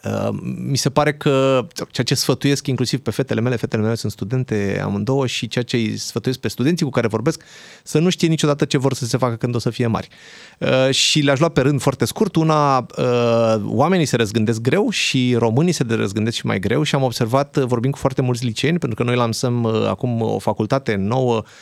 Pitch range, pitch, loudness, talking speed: 115-145 Hz, 130 Hz, -19 LUFS, 210 wpm